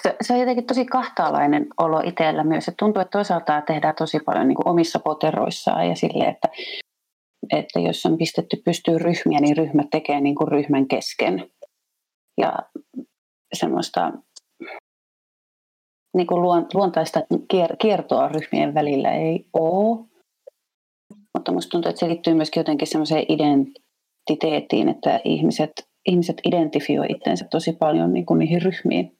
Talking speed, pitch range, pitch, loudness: 145 wpm, 155-190 Hz, 165 Hz, -21 LUFS